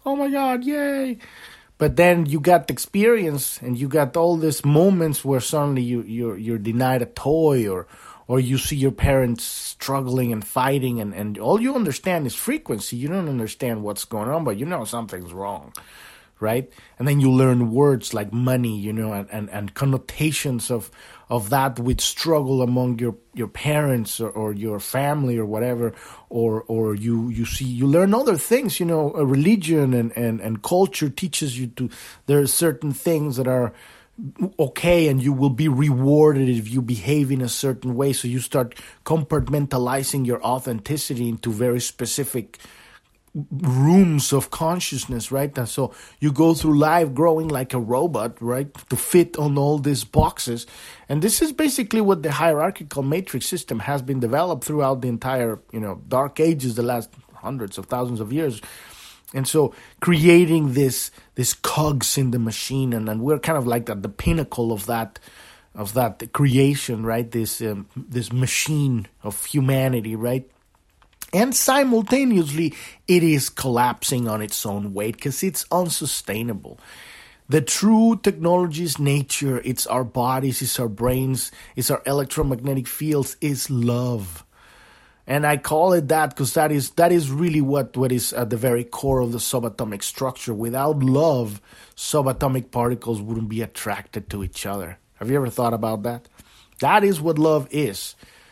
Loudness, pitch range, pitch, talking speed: -21 LUFS, 120-150 Hz, 130 Hz, 170 wpm